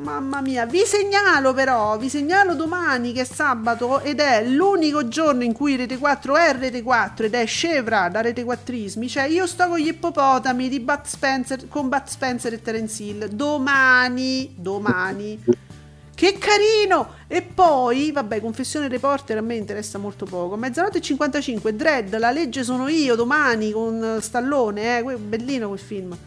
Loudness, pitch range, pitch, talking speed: -20 LUFS, 225-295 Hz, 260 Hz, 165 wpm